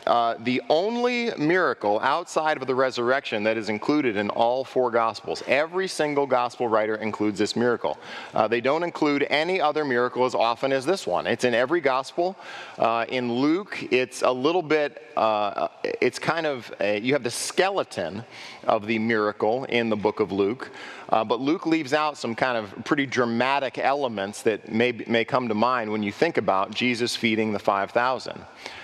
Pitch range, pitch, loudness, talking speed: 115-150 Hz, 125 Hz, -24 LUFS, 180 wpm